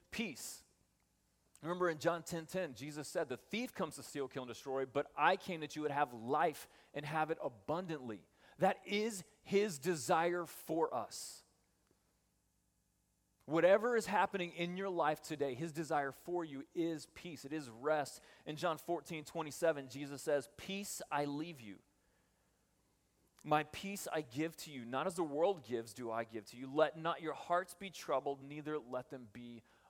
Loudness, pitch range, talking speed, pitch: -39 LUFS, 130-170 Hz, 175 wpm, 150 Hz